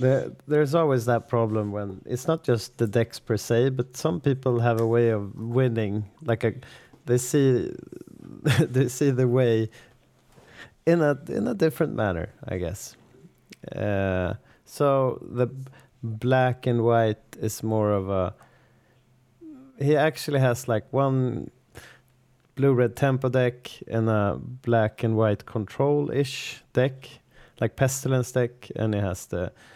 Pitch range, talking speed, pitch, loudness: 110-135 Hz, 145 wpm, 125 Hz, -25 LUFS